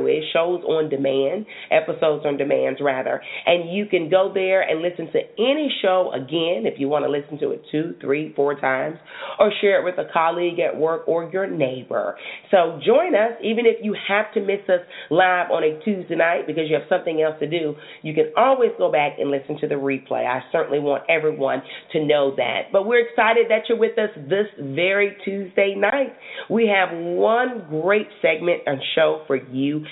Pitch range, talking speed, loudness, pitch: 150-205 Hz, 200 wpm, -21 LUFS, 170 Hz